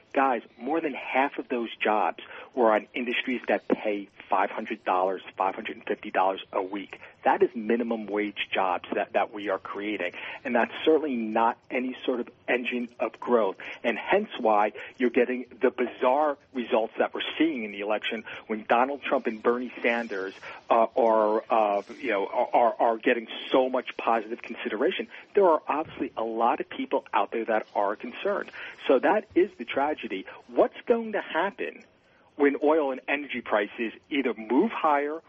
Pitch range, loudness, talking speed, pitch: 110-145 Hz, -27 LUFS, 165 wpm, 125 Hz